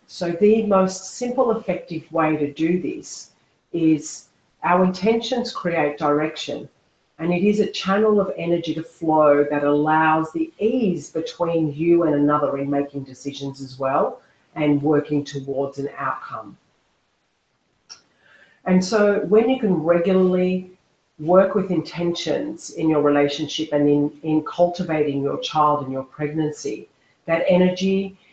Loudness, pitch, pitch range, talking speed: -21 LUFS, 160 Hz, 145-185 Hz, 135 wpm